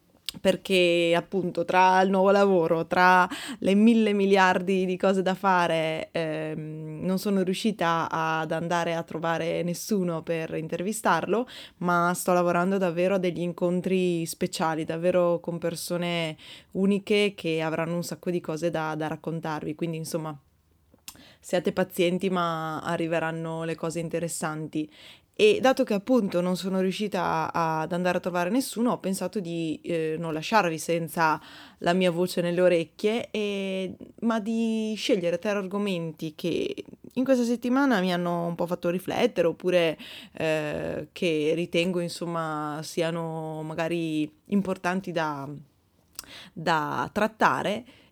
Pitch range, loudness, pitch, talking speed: 165-190 Hz, -26 LUFS, 175 Hz, 130 wpm